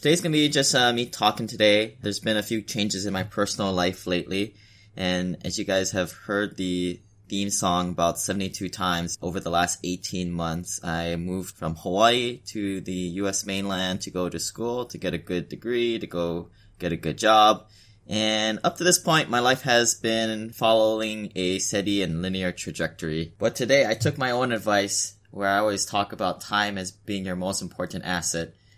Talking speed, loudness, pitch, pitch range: 190 wpm, -25 LUFS, 100 Hz, 90-110 Hz